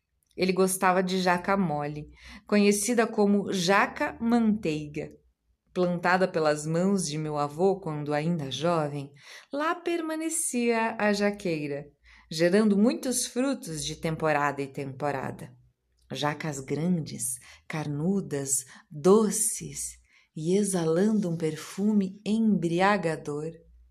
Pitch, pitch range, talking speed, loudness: 175 Hz, 150-205 Hz, 95 wpm, -27 LUFS